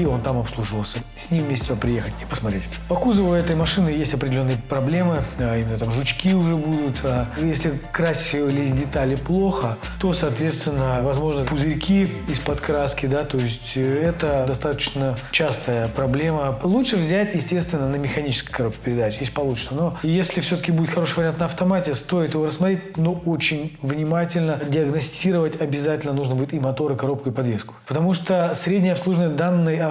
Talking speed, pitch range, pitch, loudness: 160 wpm, 135-170 Hz, 150 Hz, -22 LUFS